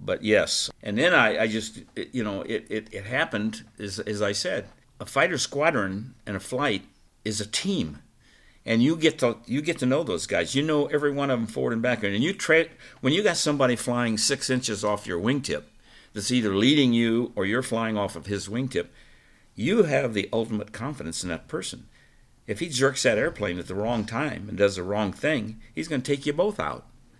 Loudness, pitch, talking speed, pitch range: -25 LUFS, 115 Hz, 220 wpm, 105-135 Hz